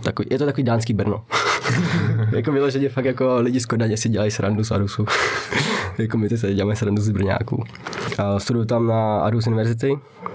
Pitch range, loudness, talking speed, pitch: 105-125 Hz, -21 LUFS, 190 wpm, 115 Hz